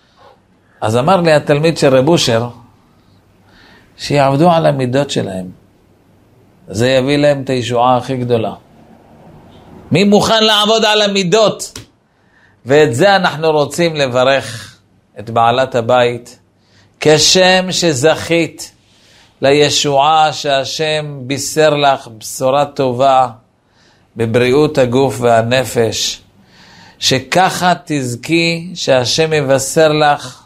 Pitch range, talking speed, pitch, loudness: 120-160 Hz, 95 wpm, 135 Hz, -12 LUFS